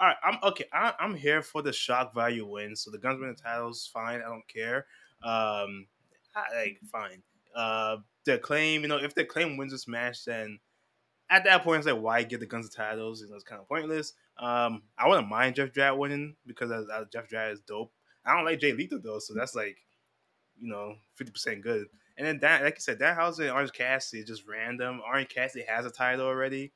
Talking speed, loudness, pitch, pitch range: 220 wpm, -29 LUFS, 120 Hz, 110-140 Hz